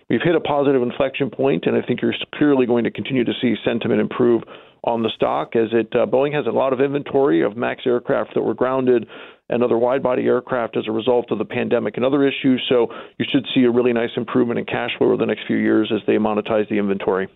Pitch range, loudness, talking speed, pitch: 110-140 Hz, -19 LUFS, 245 wpm, 120 Hz